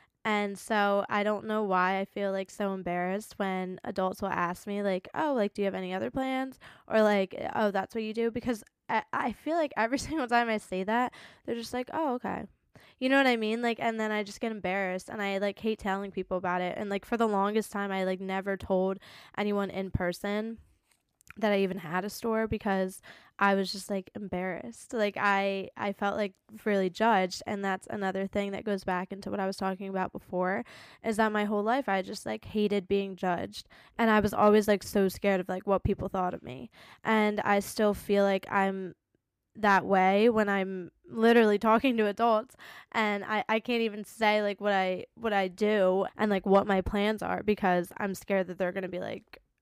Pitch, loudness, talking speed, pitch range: 200 Hz, -29 LUFS, 220 wpm, 190-220 Hz